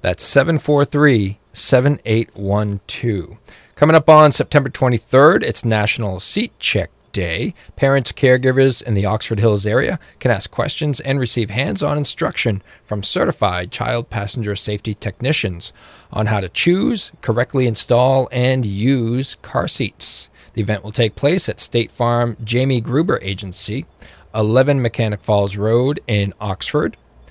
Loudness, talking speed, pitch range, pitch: -17 LUFS, 135 wpm, 105-135 Hz, 115 Hz